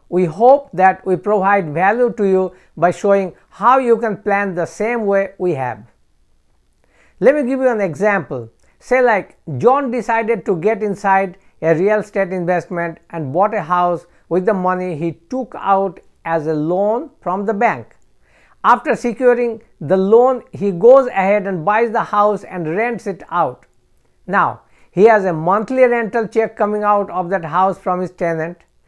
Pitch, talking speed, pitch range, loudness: 195 Hz, 170 wpm, 175-225 Hz, -16 LUFS